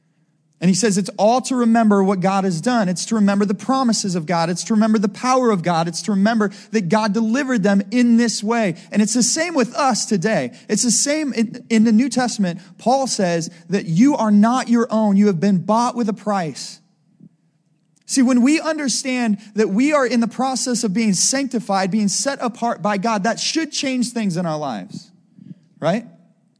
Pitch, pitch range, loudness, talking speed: 220 Hz, 195-240 Hz, -18 LUFS, 205 wpm